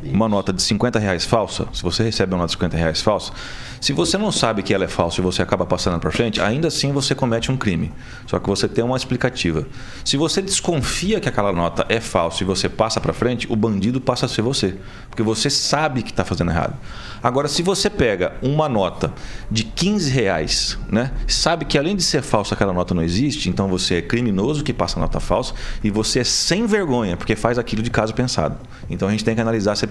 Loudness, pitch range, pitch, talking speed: -20 LUFS, 95-130 Hz, 115 Hz, 230 wpm